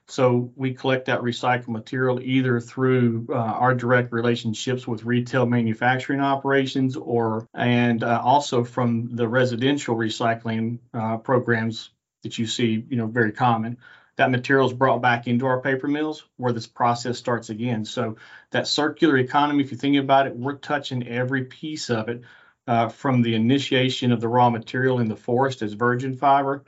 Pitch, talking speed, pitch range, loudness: 125 Hz, 165 wpm, 120-130 Hz, -23 LUFS